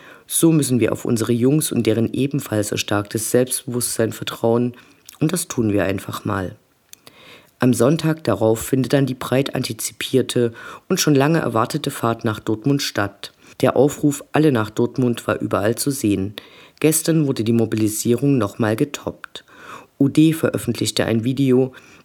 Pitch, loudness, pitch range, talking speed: 120 Hz, -19 LUFS, 115-140 Hz, 145 wpm